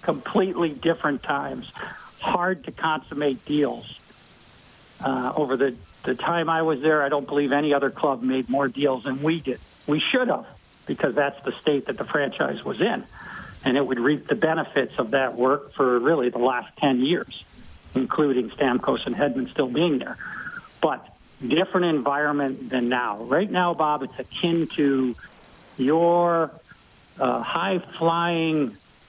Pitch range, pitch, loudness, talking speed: 130-165 Hz, 145 Hz, -24 LUFS, 155 wpm